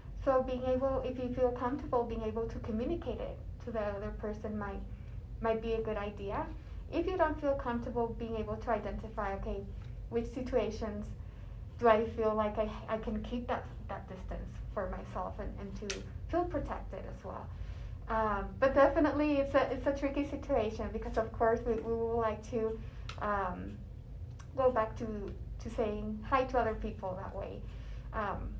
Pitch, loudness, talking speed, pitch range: 230 Hz, -35 LUFS, 175 wpm, 220-265 Hz